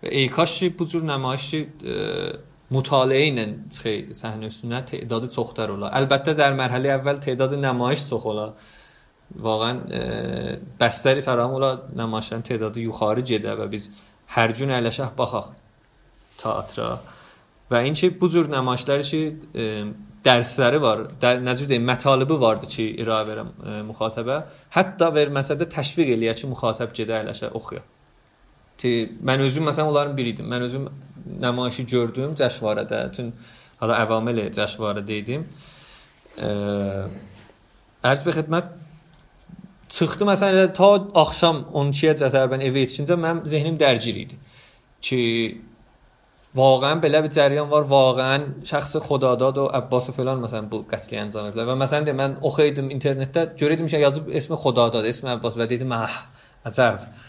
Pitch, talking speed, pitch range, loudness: 130 Hz, 130 wpm, 115-150 Hz, -22 LUFS